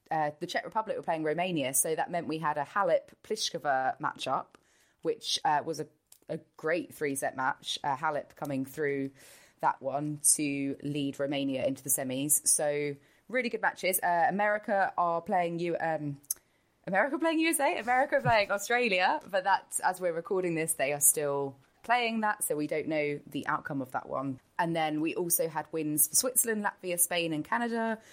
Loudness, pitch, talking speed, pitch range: -30 LUFS, 165 Hz, 175 wpm, 145-210 Hz